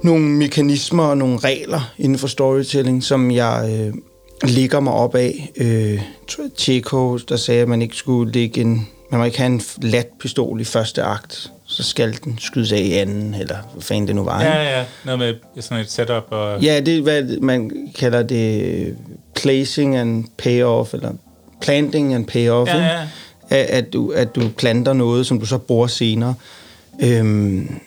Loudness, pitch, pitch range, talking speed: -18 LUFS, 125 Hz, 115-135 Hz, 165 wpm